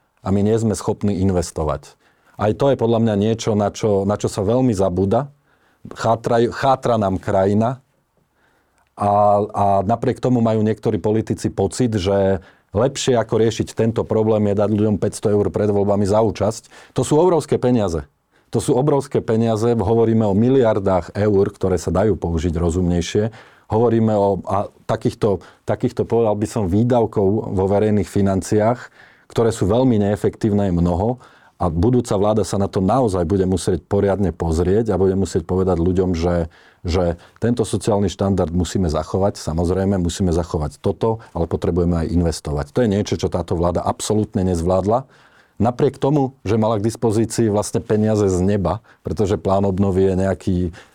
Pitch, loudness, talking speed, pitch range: 100 Hz, -19 LUFS, 160 wpm, 95-115 Hz